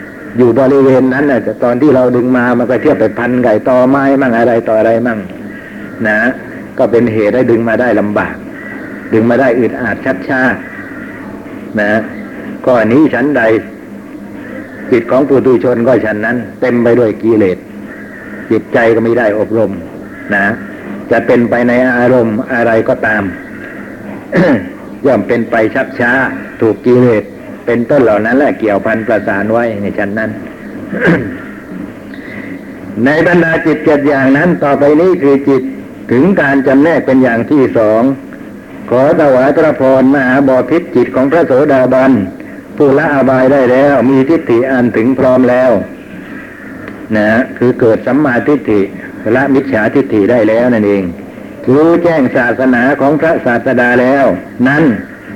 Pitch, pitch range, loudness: 125 Hz, 115-135 Hz, -10 LUFS